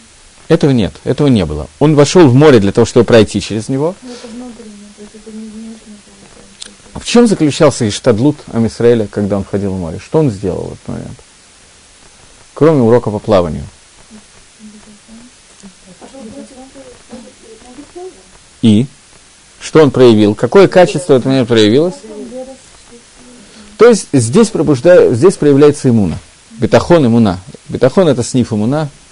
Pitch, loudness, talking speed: 150 Hz, -10 LUFS, 120 wpm